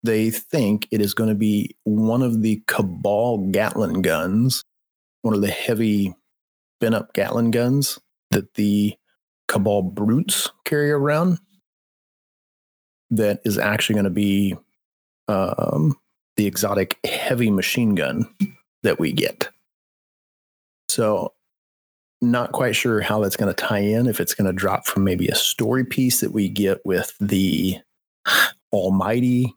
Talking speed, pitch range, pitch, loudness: 140 wpm, 100-120 Hz, 105 Hz, -21 LUFS